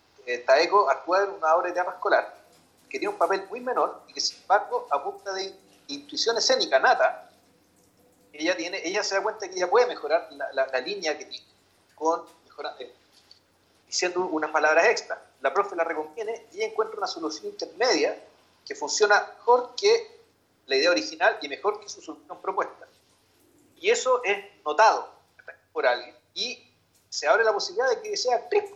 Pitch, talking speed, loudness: 205 Hz, 175 wpm, -25 LUFS